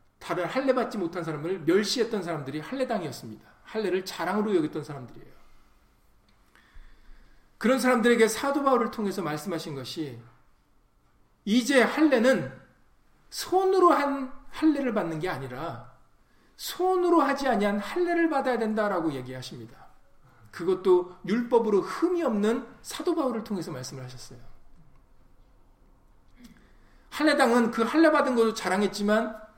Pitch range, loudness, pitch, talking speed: 165-260 Hz, -26 LUFS, 215 Hz, 300 characters per minute